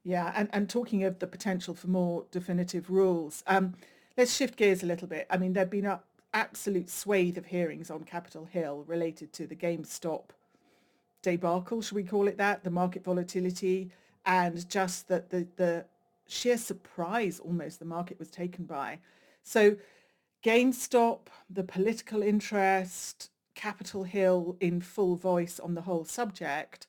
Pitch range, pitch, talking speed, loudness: 175-200 Hz, 185 Hz, 160 wpm, -31 LUFS